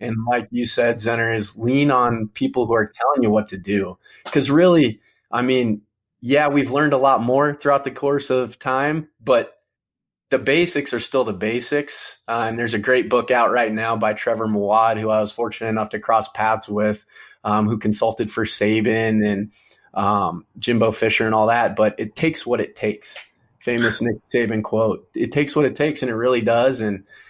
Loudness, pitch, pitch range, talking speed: -20 LUFS, 115 Hz, 110-130 Hz, 200 wpm